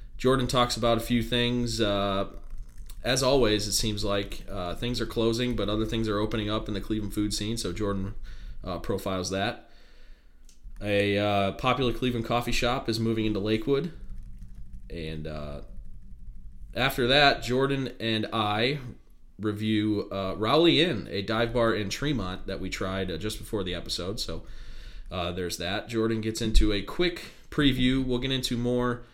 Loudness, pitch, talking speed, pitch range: -27 LUFS, 110 Hz, 165 wpm, 100-120 Hz